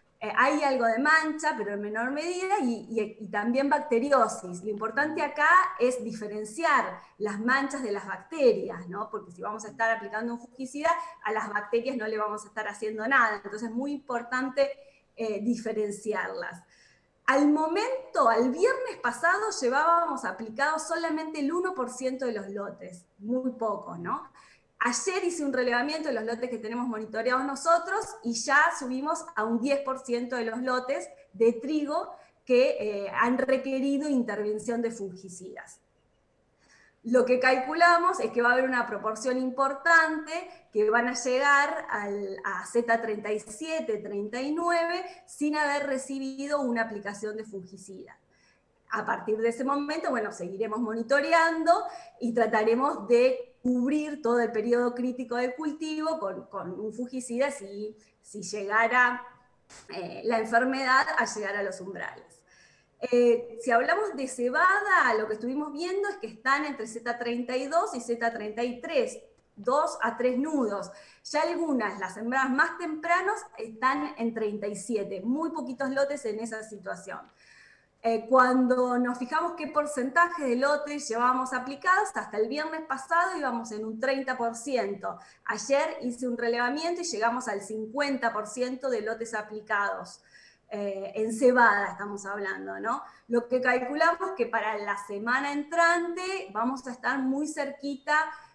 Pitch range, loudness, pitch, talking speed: 220-295 Hz, -28 LUFS, 250 Hz, 145 wpm